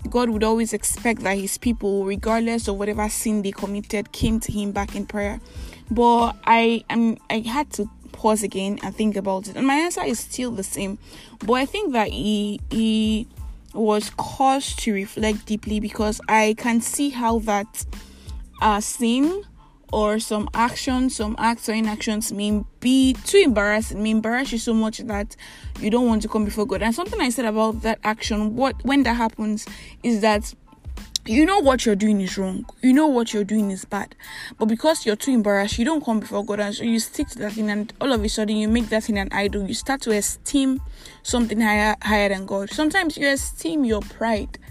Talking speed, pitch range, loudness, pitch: 200 wpm, 210-240 Hz, -22 LUFS, 220 Hz